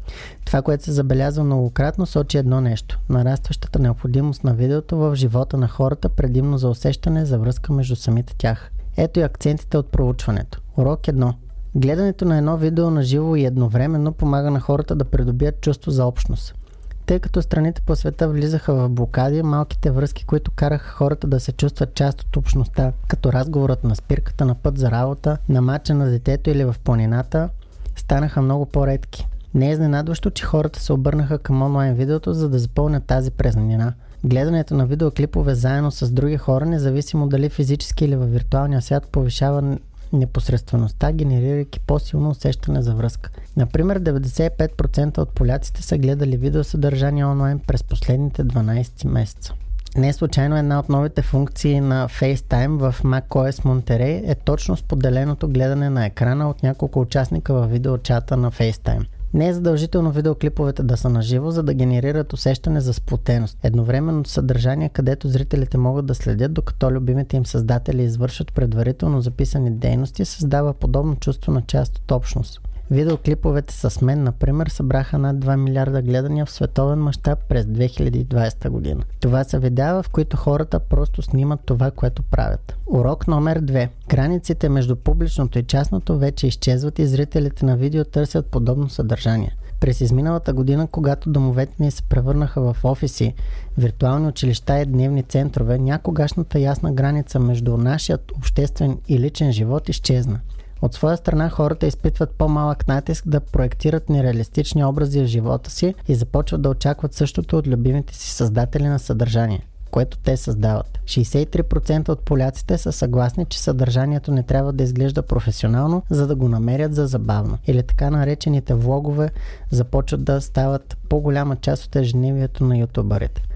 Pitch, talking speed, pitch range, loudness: 135 Hz, 155 wpm, 125-150 Hz, -20 LUFS